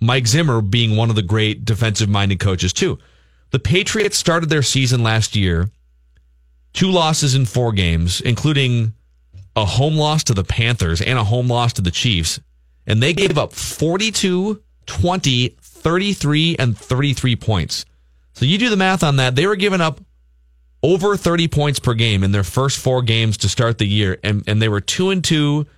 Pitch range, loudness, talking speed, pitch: 100-150 Hz, -17 LUFS, 185 wpm, 120 Hz